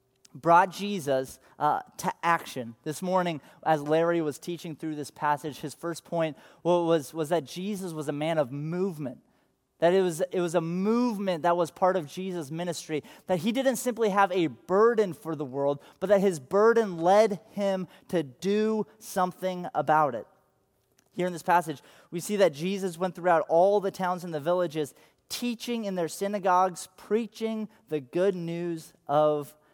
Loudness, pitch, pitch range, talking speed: -28 LUFS, 175 Hz, 155-195 Hz, 175 wpm